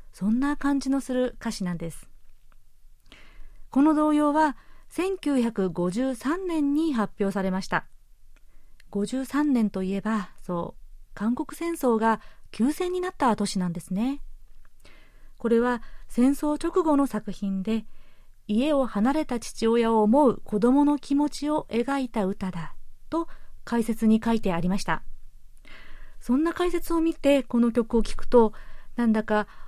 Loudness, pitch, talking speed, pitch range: -25 LUFS, 235 Hz, 245 characters per minute, 205-285 Hz